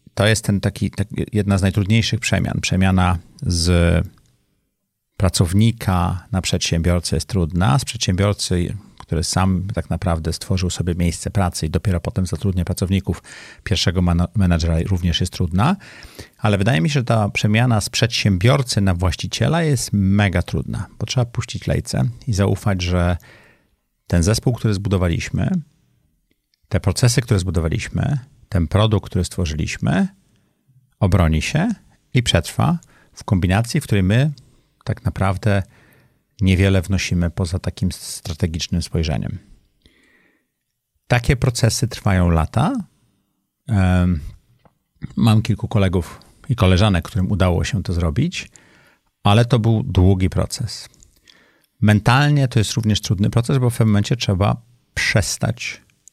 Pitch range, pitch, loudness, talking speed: 90-115 Hz, 100 Hz, -19 LUFS, 125 wpm